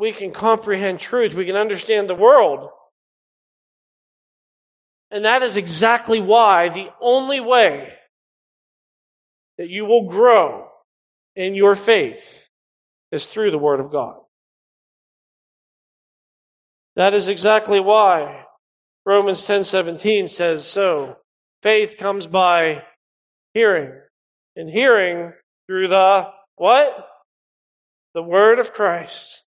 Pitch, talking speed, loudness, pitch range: 205 Hz, 105 wpm, -17 LUFS, 190-225 Hz